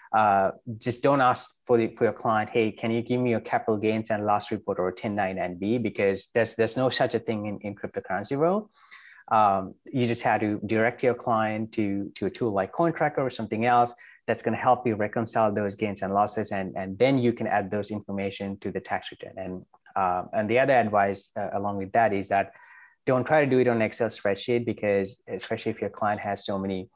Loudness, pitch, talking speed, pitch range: -26 LUFS, 110 Hz, 225 wpm, 100-120 Hz